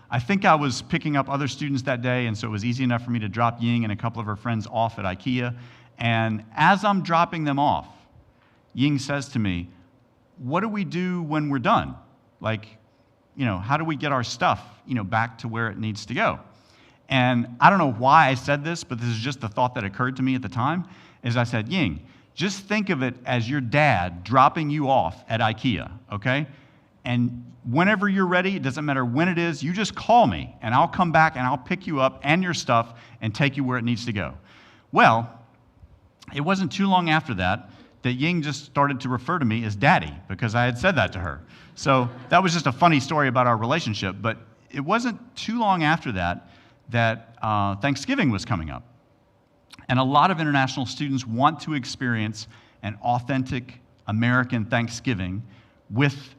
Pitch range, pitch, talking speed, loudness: 115-150 Hz, 125 Hz, 210 wpm, -23 LUFS